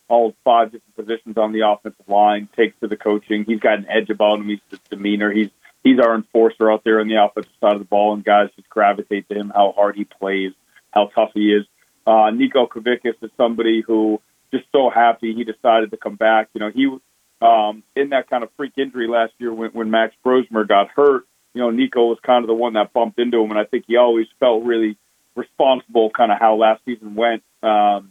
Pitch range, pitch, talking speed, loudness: 105-115 Hz, 110 Hz, 230 wpm, -18 LUFS